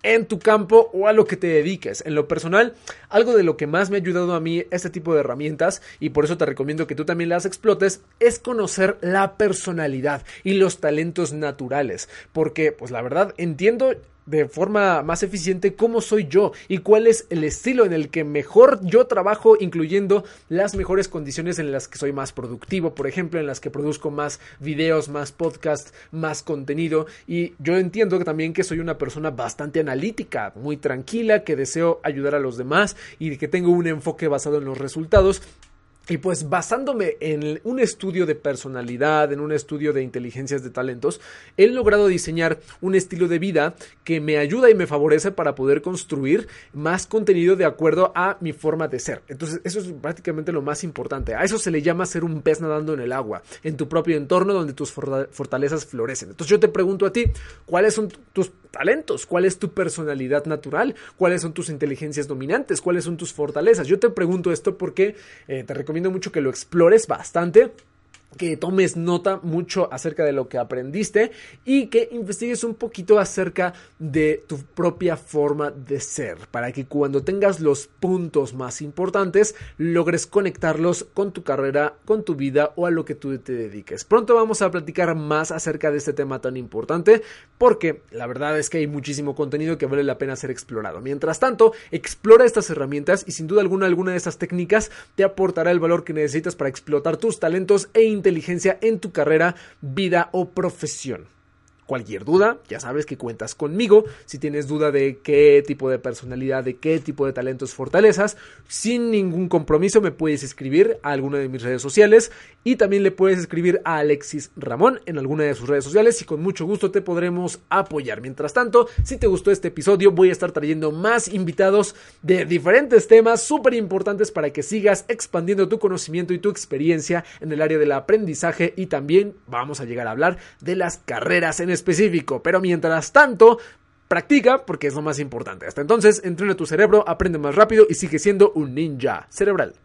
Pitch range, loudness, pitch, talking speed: 150-195 Hz, -20 LUFS, 170 Hz, 190 wpm